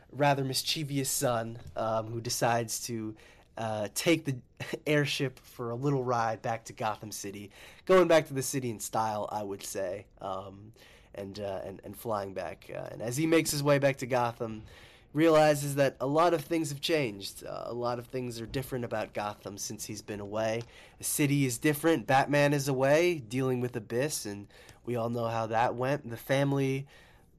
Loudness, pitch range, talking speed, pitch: -30 LUFS, 110-140 Hz, 190 wpm, 120 Hz